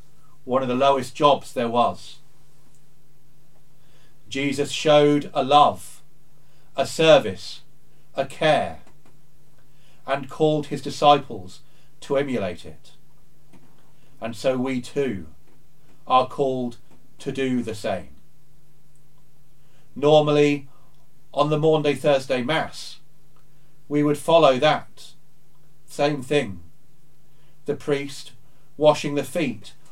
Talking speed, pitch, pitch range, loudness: 100 wpm, 145 Hz, 140-150 Hz, -22 LUFS